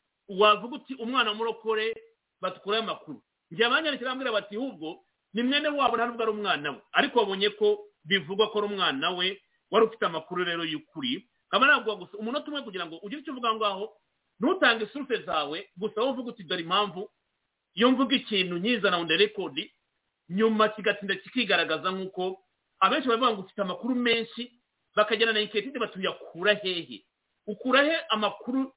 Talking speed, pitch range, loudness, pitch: 150 wpm, 195-245 Hz, -27 LUFS, 215 Hz